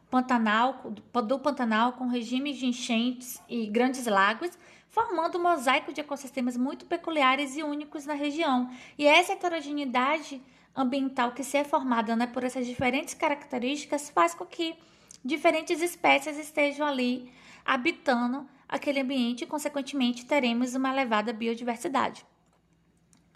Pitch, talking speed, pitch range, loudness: 265 Hz, 130 wpm, 245-295 Hz, -28 LUFS